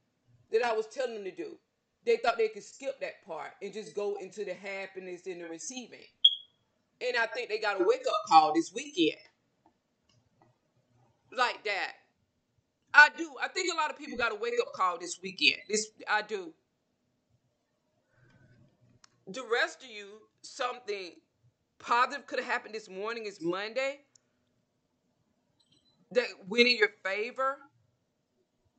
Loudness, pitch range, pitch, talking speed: -30 LUFS, 190-300 Hz, 235 Hz, 145 wpm